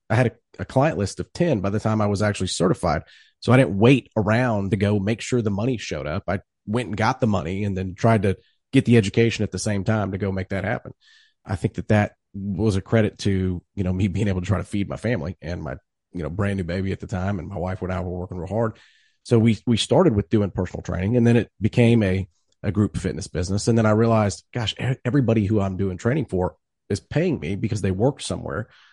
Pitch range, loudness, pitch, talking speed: 95-115 Hz, -23 LUFS, 105 Hz, 255 wpm